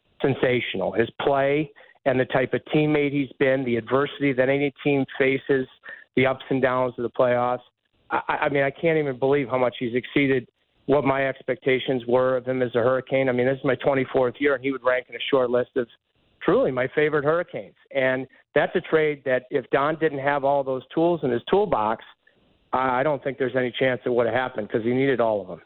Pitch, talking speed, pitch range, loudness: 130 Hz, 220 wpm, 125-140 Hz, -23 LUFS